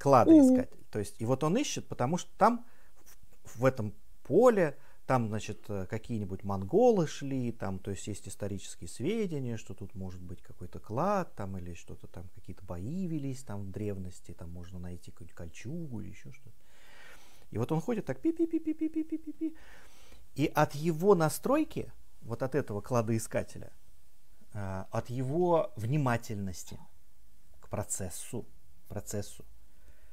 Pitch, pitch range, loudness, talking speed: 110 Hz, 95-155 Hz, -31 LUFS, 135 wpm